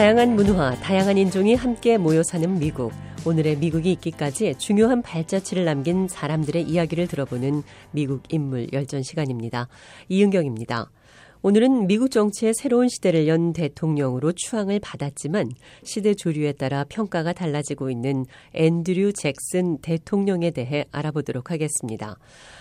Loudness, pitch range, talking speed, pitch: -23 LUFS, 140-195 Hz, 350 characters per minute, 160 Hz